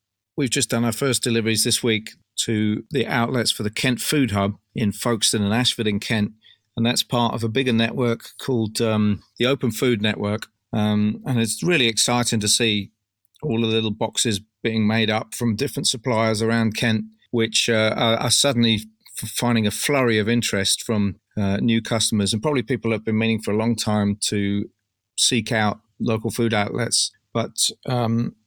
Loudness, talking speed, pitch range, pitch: -21 LUFS, 180 wpm, 105-120 Hz, 115 Hz